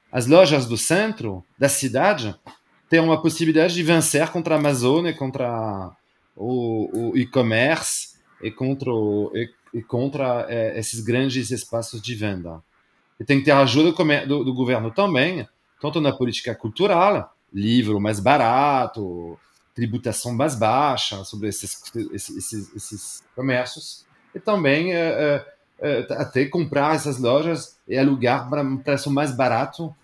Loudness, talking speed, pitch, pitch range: -21 LUFS, 140 wpm, 130 Hz, 115-150 Hz